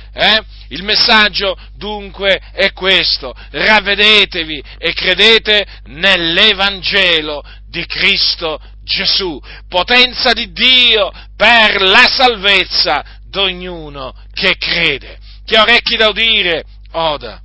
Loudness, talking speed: -10 LUFS, 95 wpm